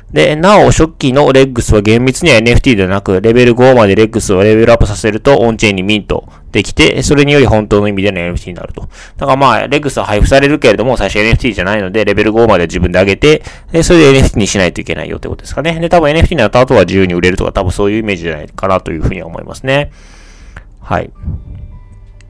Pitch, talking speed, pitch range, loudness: 105 Hz, 505 characters per minute, 95-130 Hz, -9 LUFS